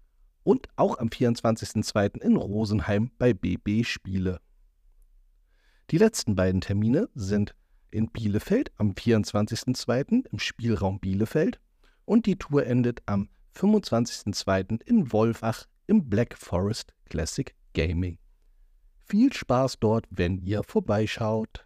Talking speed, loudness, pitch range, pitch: 110 wpm, -26 LUFS, 95-120 Hz, 110 Hz